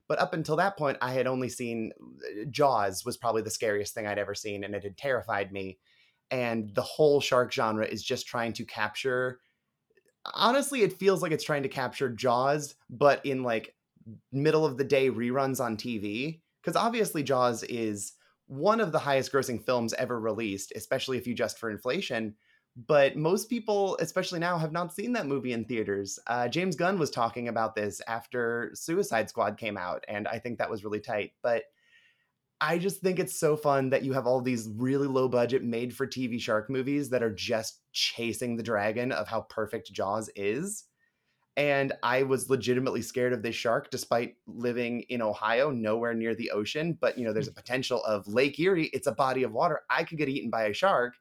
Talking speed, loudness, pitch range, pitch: 200 wpm, -29 LUFS, 115-145 Hz, 125 Hz